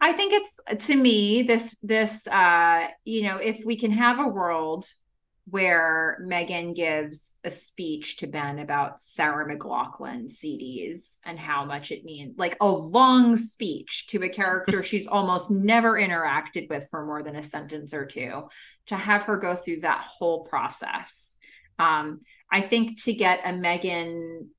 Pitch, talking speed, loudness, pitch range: 185 Hz, 160 wpm, -24 LUFS, 165-225 Hz